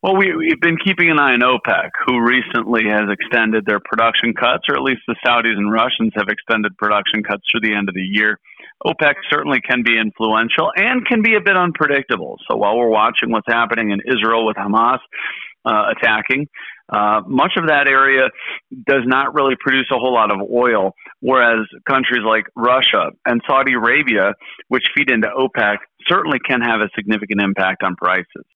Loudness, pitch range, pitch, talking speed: -15 LUFS, 105-135 Hz, 115 Hz, 185 wpm